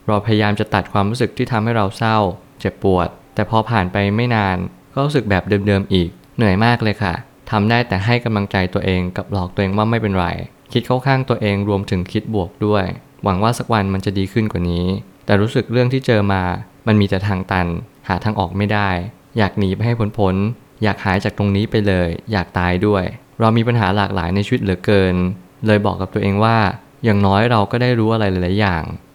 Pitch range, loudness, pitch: 95-115 Hz, -18 LUFS, 105 Hz